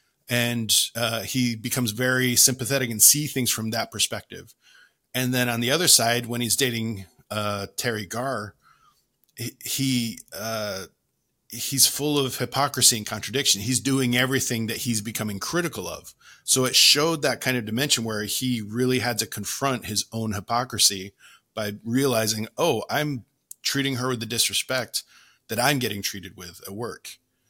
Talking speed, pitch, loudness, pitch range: 155 wpm, 120 Hz, -22 LUFS, 110-130 Hz